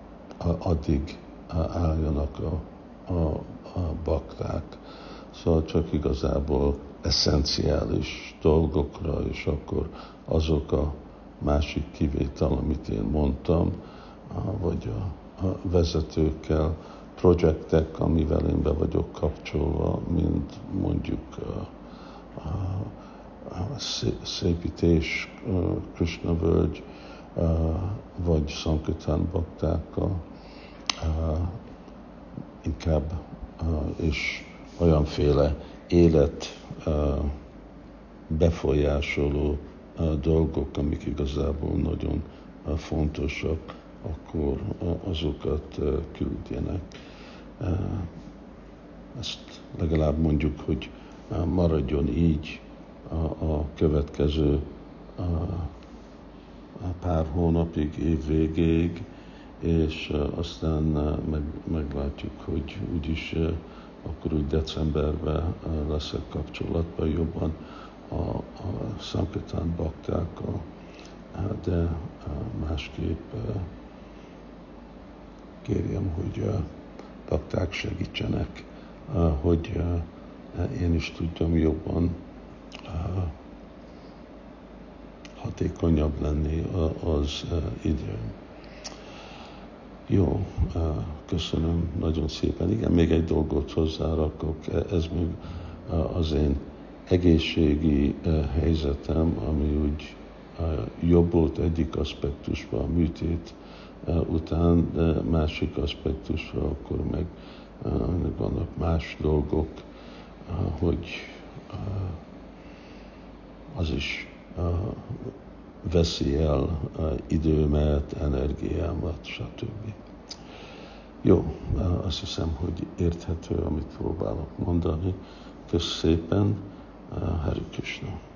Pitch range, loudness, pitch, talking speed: 75-85 Hz, -28 LUFS, 80 Hz, 75 wpm